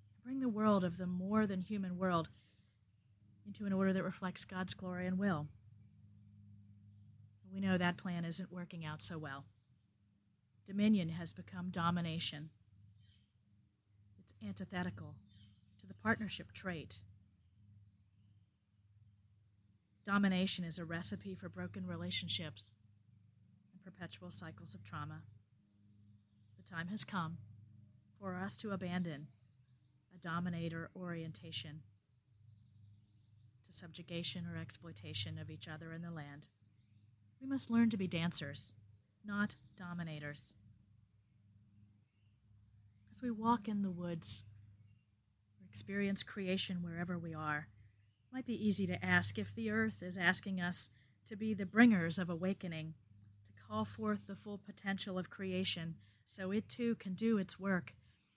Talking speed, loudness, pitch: 125 wpm, -39 LUFS, 145 Hz